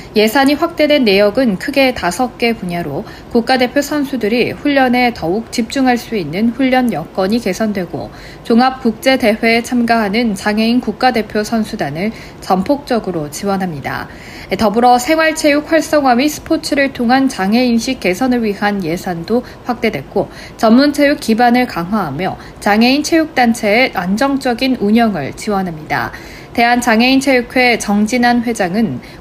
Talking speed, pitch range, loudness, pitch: 320 characters per minute, 200-260 Hz, -14 LUFS, 235 Hz